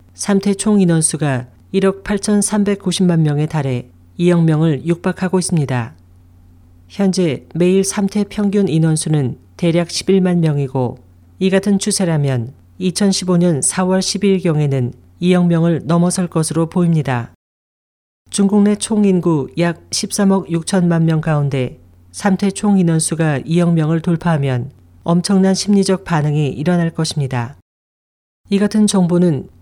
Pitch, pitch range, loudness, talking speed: 170 Hz, 135-190 Hz, -16 LUFS, 235 characters per minute